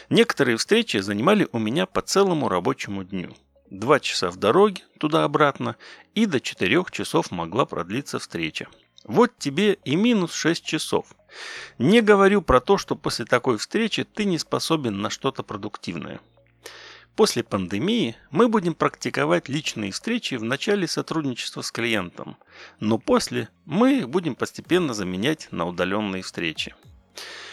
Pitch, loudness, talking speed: 160 Hz, -23 LUFS, 135 wpm